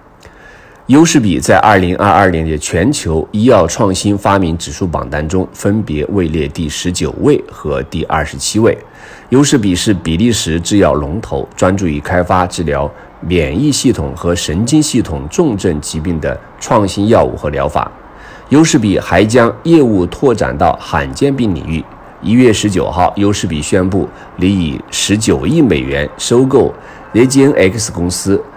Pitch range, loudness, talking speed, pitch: 80-105 Hz, -12 LUFS, 245 characters per minute, 95 Hz